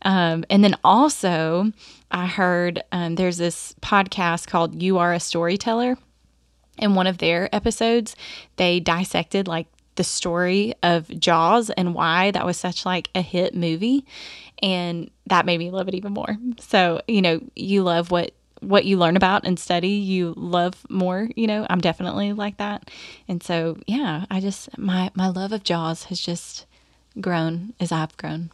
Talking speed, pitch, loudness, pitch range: 170 wpm, 185 Hz, -22 LUFS, 175-205 Hz